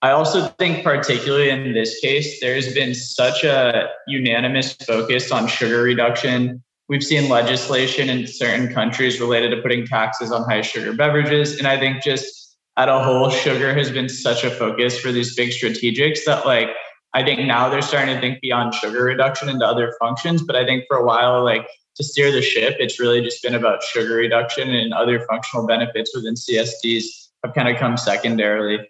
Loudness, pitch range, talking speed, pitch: -18 LUFS, 115-135 Hz, 190 wpm, 125 Hz